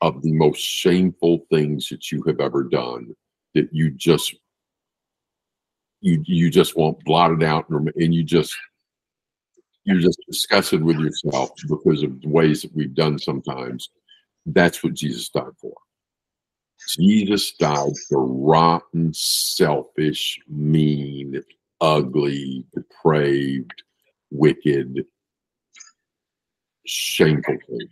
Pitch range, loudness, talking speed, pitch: 70-85 Hz, -20 LUFS, 110 wpm, 80 Hz